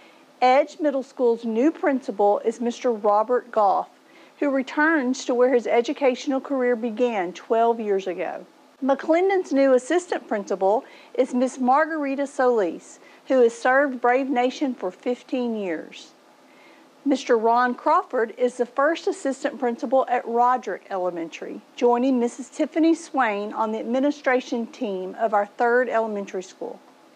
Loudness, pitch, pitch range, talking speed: -23 LUFS, 250 Hz, 230-275 Hz, 135 wpm